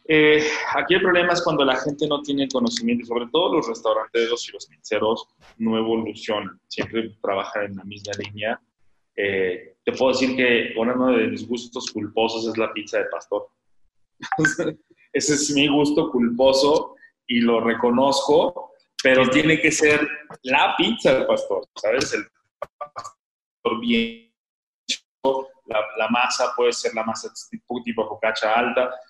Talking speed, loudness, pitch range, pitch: 150 wpm, -21 LUFS, 115-155 Hz, 130 Hz